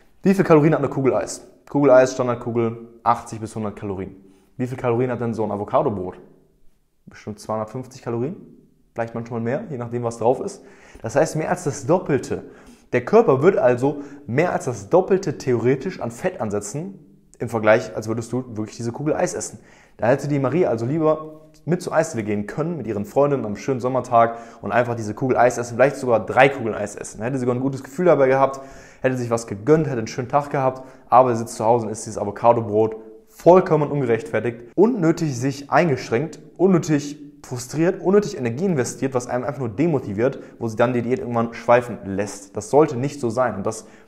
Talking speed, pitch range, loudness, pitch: 200 wpm, 115-145 Hz, -21 LUFS, 125 Hz